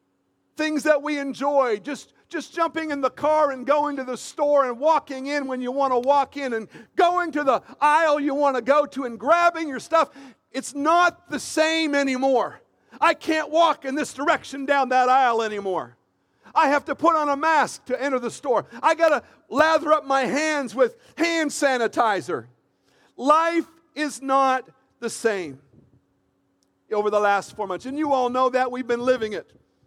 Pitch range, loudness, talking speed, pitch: 250-310 Hz, -22 LUFS, 185 wpm, 280 Hz